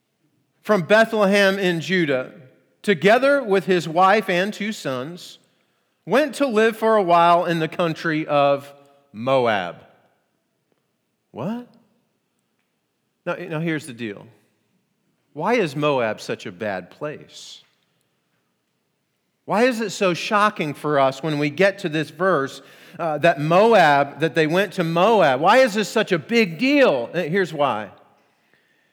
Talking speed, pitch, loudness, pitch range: 135 wpm, 175 Hz, -19 LUFS, 150-210 Hz